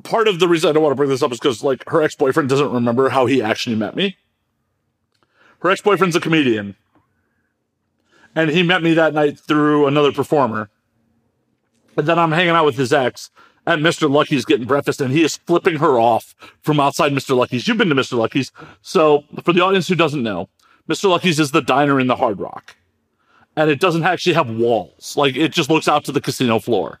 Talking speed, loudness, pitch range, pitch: 210 wpm, -17 LUFS, 125-165 Hz, 145 Hz